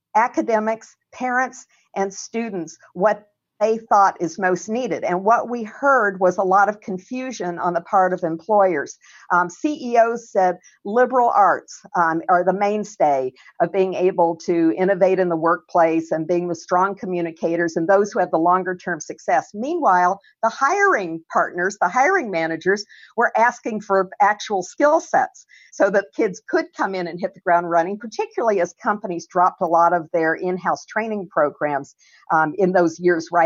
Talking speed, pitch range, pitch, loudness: 170 wpm, 175-225 Hz, 190 Hz, -20 LUFS